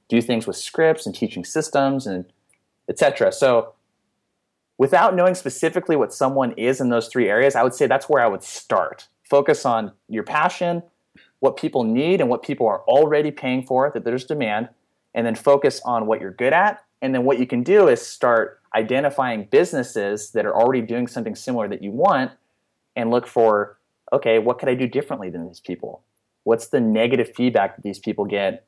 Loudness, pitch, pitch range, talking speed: -20 LUFS, 125 Hz, 115-140 Hz, 195 wpm